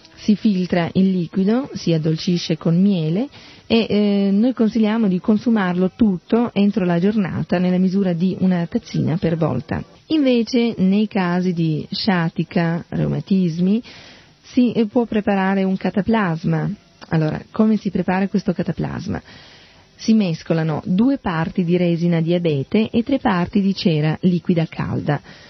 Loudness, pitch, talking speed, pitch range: -19 LUFS, 190 Hz, 130 wpm, 175-215 Hz